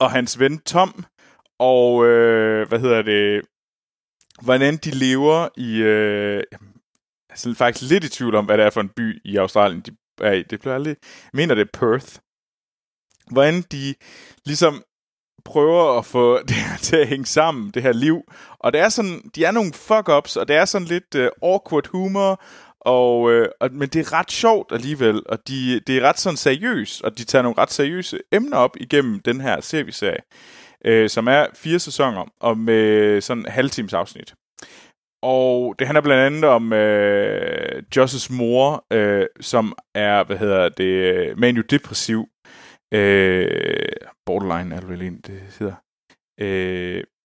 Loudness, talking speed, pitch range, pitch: -19 LUFS, 165 wpm, 110-150 Hz, 125 Hz